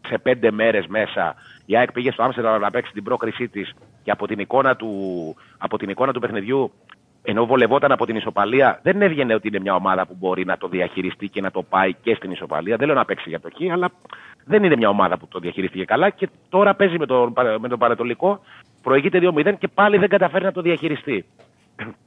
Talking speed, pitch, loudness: 205 wpm, 120 Hz, -20 LUFS